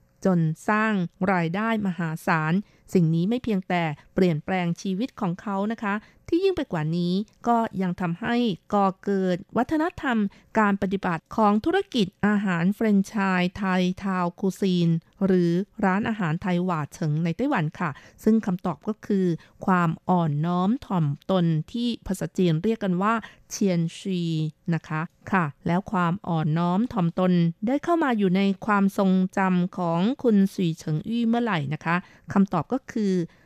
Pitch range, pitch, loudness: 170-215 Hz, 190 Hz, -25 LUFS